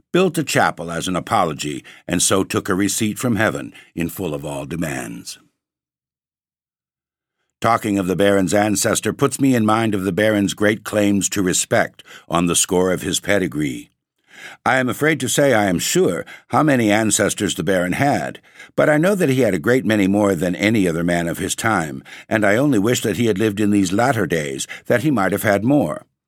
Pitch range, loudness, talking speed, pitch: 90-115 Hz, -18 LUFS, 205 wpm, 100 Hz